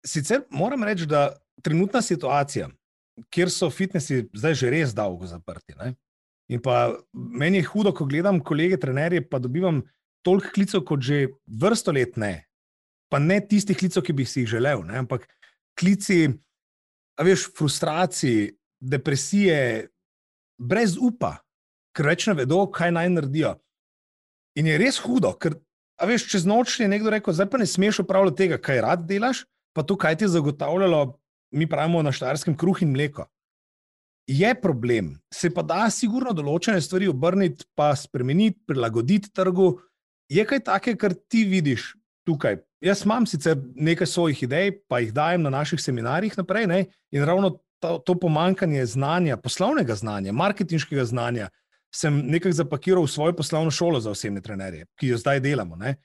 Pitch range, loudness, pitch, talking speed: 135-190 Hz, -23 LUFS, 165 Hz, 155 wpm